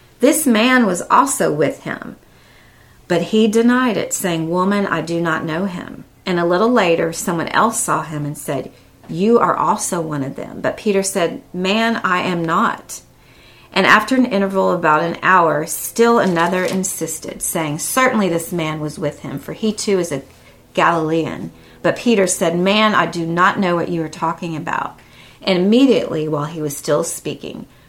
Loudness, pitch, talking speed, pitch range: -17 LUFS, 180 Hz, 180 wpm, 160-210 Hz